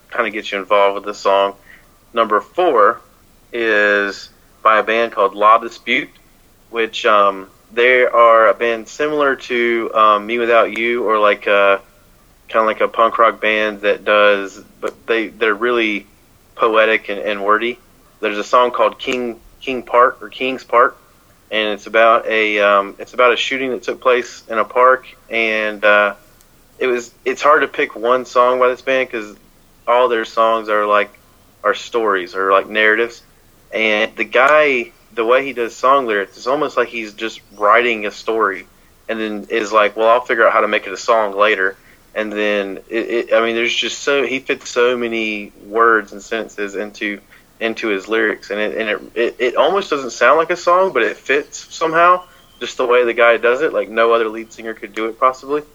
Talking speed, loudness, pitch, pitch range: 195 wpm, -15 LUFS, 115 Hz, 105-120 Hz